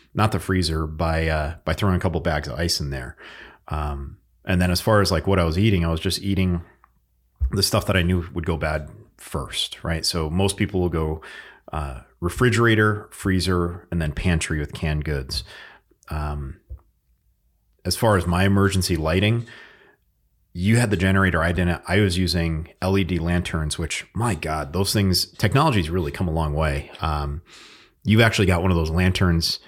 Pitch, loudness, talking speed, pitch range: 85 Hz, -22 LUFS, 180 wpm, 80-95 Hz